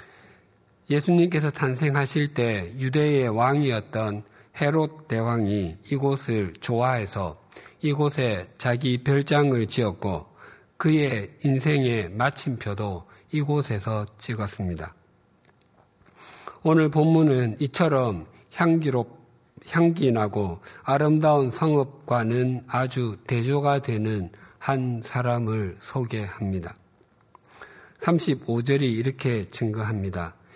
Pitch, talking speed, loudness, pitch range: 125 Hz, 210 characters per minute, -25 LUFS, 105-145 Hz